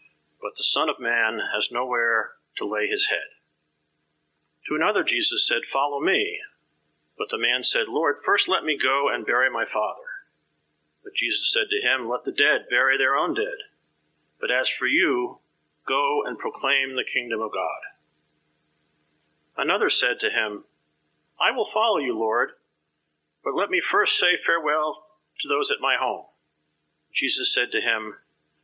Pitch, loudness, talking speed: 165 Hz, -22 LUFS, 160 wpm